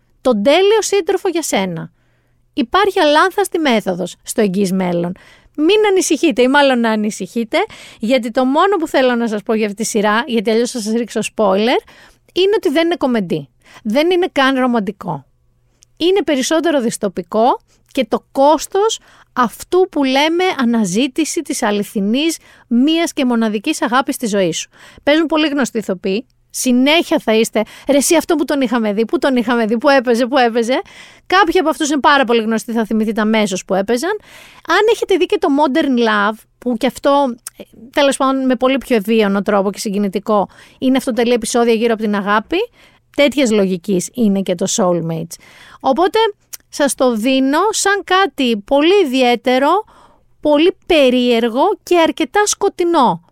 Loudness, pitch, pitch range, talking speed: -15 LUFS, 255 Hz, 220-320 Hz, 160 wpm